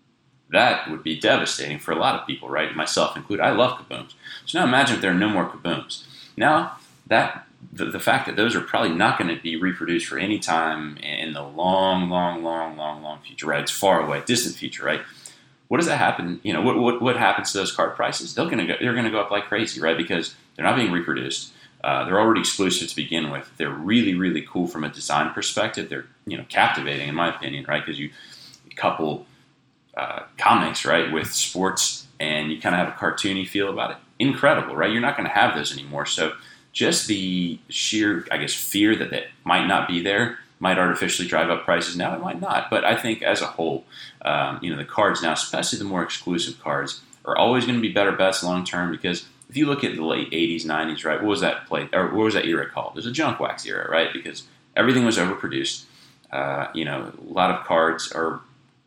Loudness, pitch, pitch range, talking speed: -23 LUFS, 90 Hz, 80-105 Hz, 225 wpm